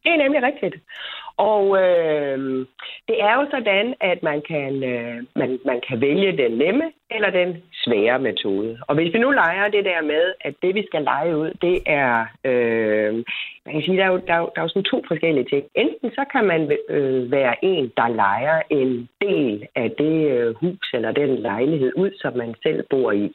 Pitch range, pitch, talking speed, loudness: 130-195 Hz, 160 Hz, 200 wpm, -20 LUFS